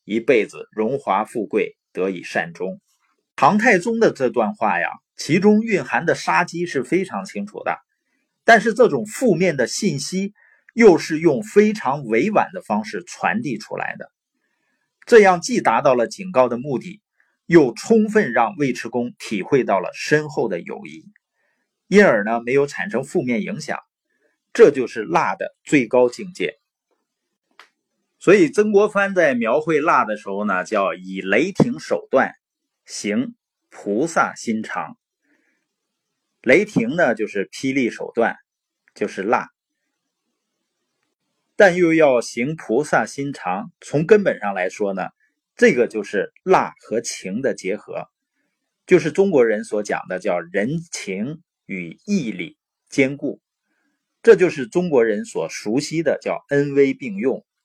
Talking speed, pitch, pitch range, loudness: 205 characters per minute, 185 Hz, 140-225 Hz, -19 LUFS